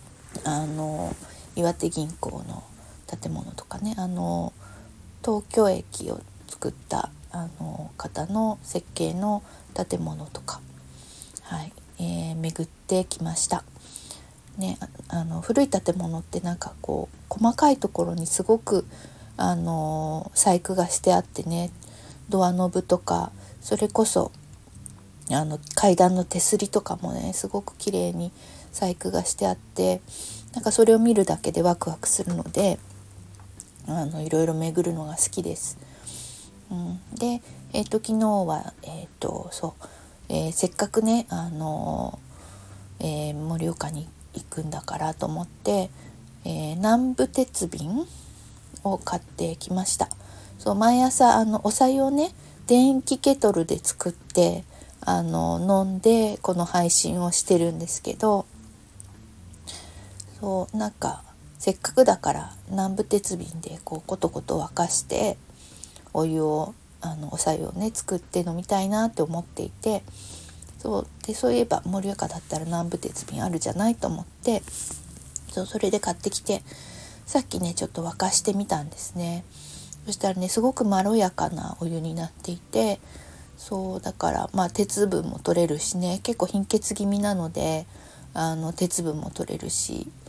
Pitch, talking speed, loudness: 170 Hz, 265 characters per minute, -25 LUFS